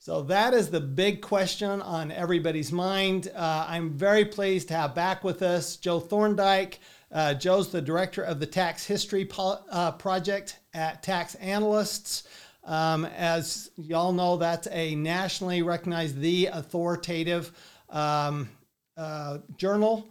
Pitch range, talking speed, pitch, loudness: 165-195 Hz, 140 wpm, 175 Hz, -28 LUFS